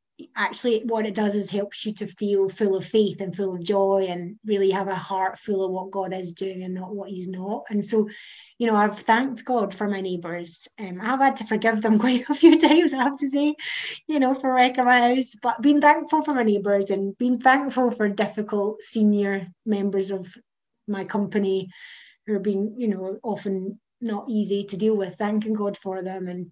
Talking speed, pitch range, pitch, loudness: 215 wpm, 195-235 Hz, 210 Hz, -23 LUFS